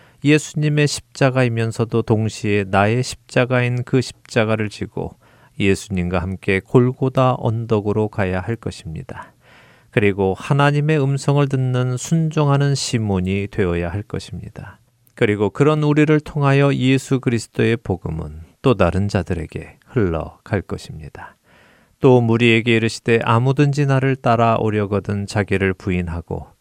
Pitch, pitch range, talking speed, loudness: 115 Hz, 100-135 Hz, 310 characters per minute, -18 LUFS